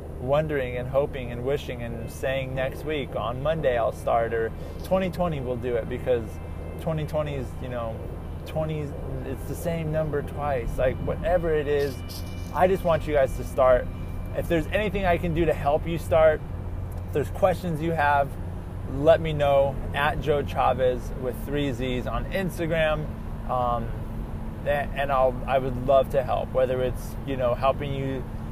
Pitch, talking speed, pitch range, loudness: 130 Hz, 170 wpm, 105-150 Hz, -26 LUFS